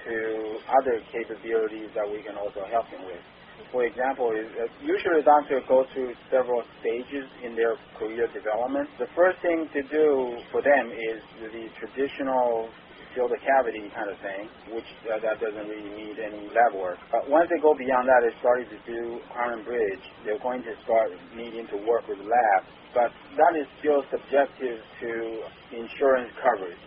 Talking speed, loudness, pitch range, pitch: 175 wpm, -26 LUFS, 110-145 Hz, 120 Hz